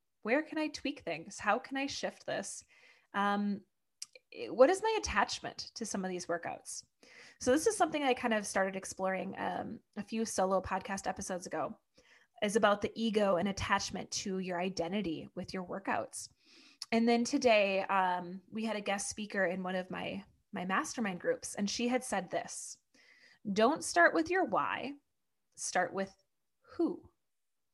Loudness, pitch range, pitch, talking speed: -34 LUFS, 190-270 Hz, 215 Hz, 165 wpm